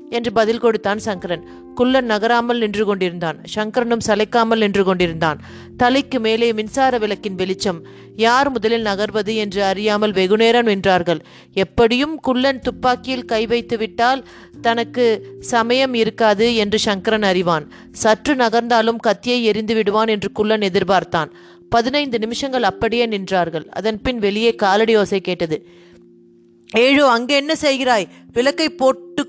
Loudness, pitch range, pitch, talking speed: -17 LUFS, 195-240 Hz, 220 Hz, 120 wpm